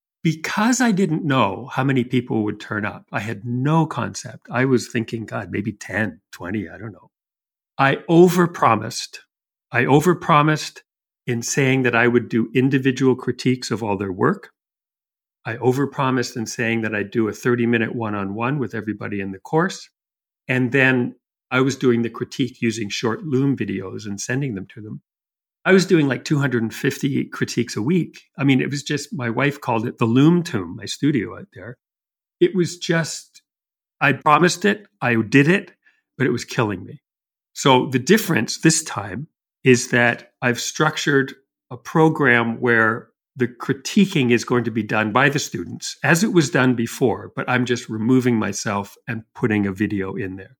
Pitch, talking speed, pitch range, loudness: 125 Hz, 180 wpm, 115-145 Hz, -20 LUFS